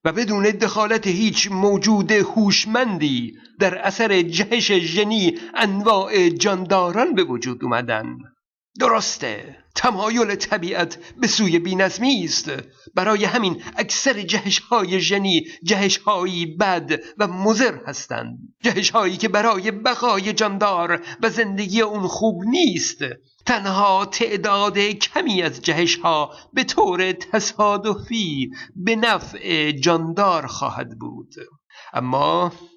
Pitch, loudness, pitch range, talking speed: 200 Hz, -19 LUFS, 180-220 Hz, 105 wpm